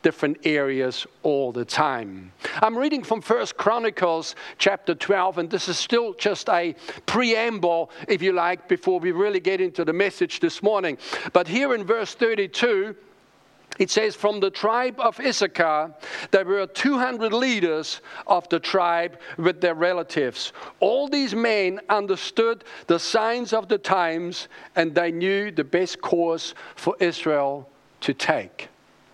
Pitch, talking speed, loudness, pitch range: 190 Hz, 150 wpm, -23 LUFS, 170-230 Hz